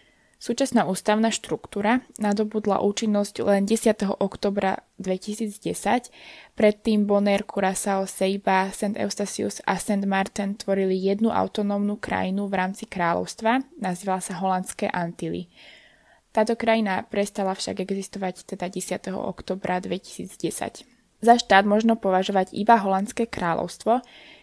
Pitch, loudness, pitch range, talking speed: 200 Hz, -24 LUFS, 190-215 Hz, 110 wpm